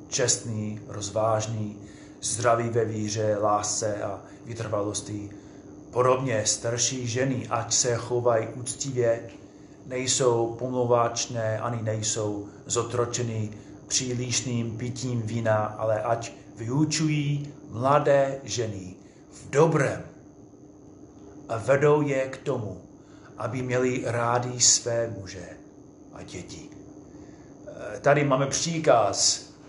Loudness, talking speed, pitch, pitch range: -25 LUFS, 90 wpm, 115 Hz, 110-130 Hz